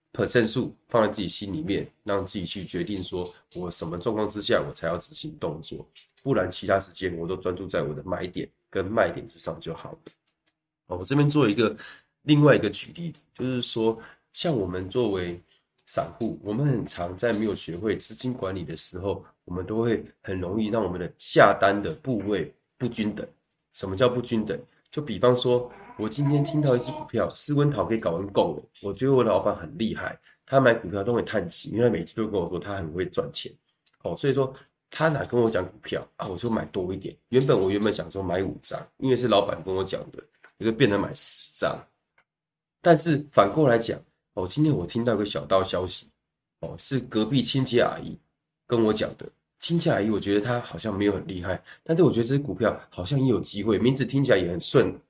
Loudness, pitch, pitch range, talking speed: -25 LUFS, 115 Hz, 95-135 Hz, 305 characters per minute